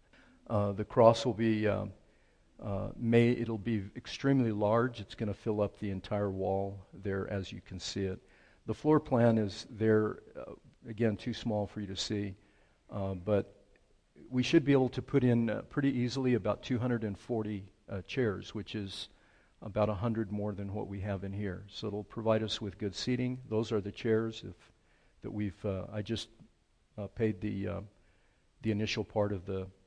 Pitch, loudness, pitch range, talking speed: 105 Hz, -33 LUFS, 100-115 Hz, 190 wpm